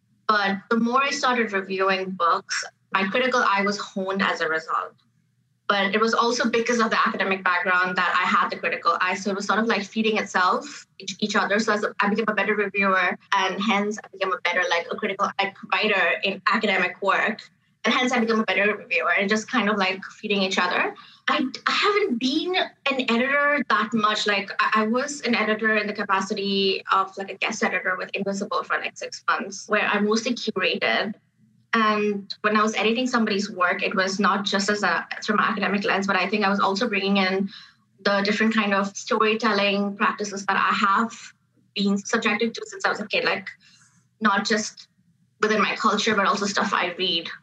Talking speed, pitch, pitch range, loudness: 200 wpm, 205 Hz, 195-225 Hz, -22 LUFS